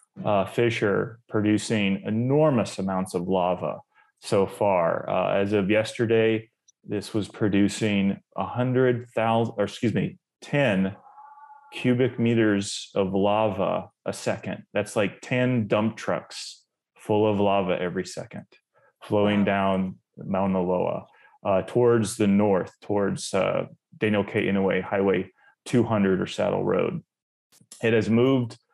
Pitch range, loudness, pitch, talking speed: 100-115 Hz, -25 LUFS, 105 Hz, 125 wpm